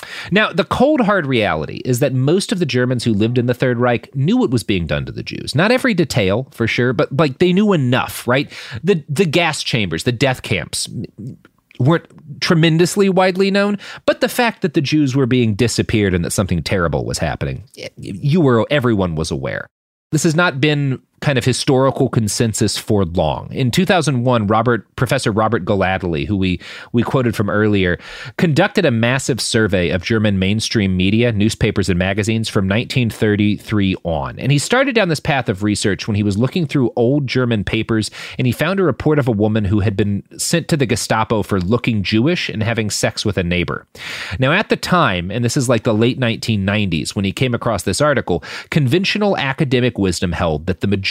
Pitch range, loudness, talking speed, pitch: 105-150 Hz, -17 LUFS, 195 wpm, 120 Hz